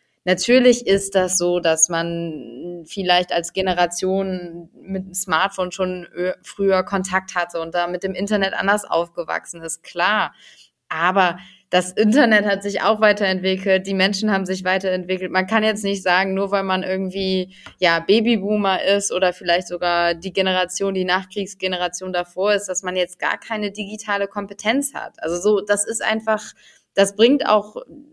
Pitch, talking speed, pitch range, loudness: 190 Hz, 160 wpm, 180-200 Hz, -20 LUFS